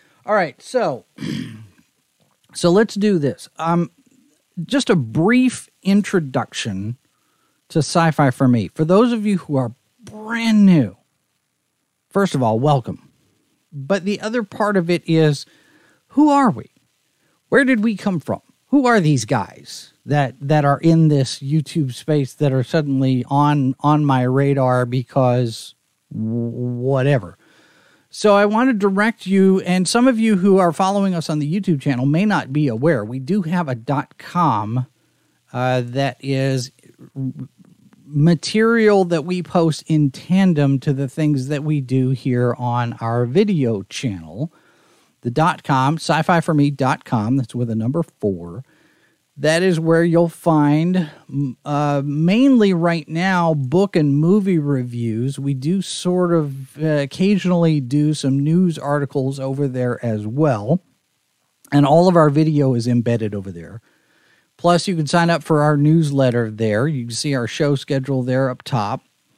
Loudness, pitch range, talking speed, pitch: -18 LUFS, 130-175 Hz, 150 wpm, 150 Hz